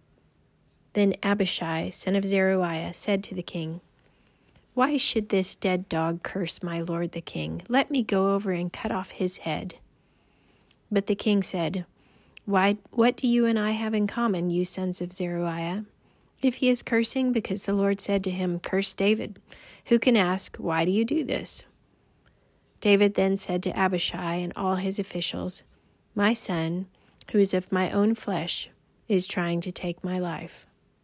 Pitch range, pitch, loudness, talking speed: 175-210 Hz, 190 Hz, -25 LUFS, 170 wpm